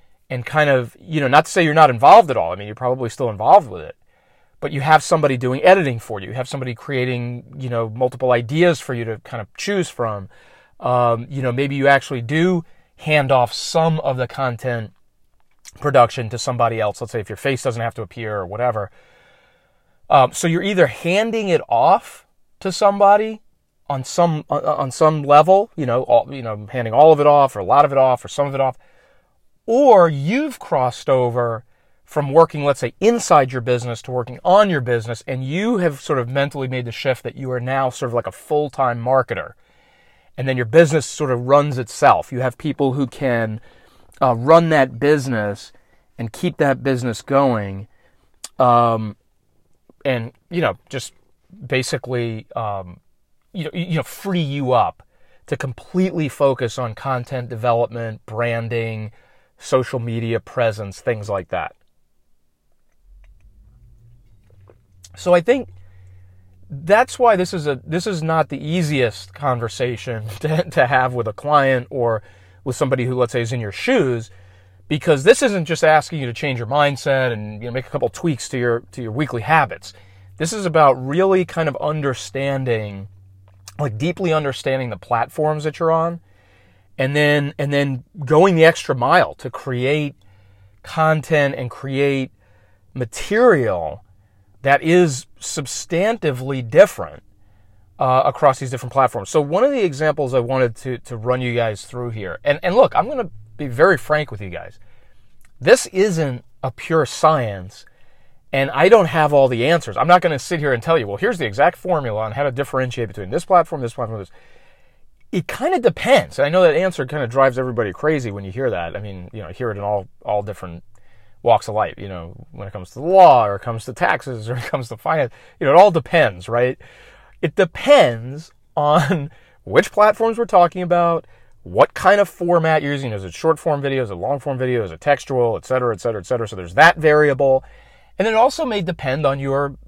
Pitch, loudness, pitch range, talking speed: 130 Hz, -18 LUFS, 115-155 Hz, 190 wpm